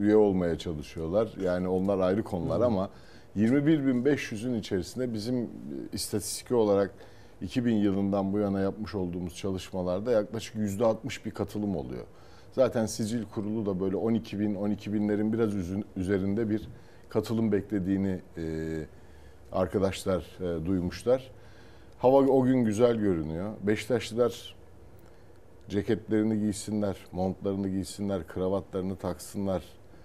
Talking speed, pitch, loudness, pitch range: 105 wpm, 100 Hz, -29 LUFS, 95-110 Hz